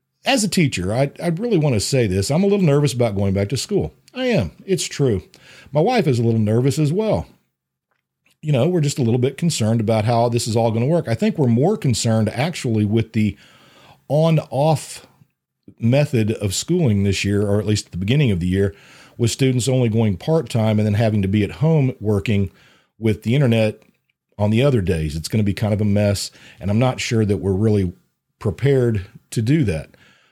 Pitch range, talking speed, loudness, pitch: 105-145 Hz, 215 wpm, -19 LUFS, 120 Hz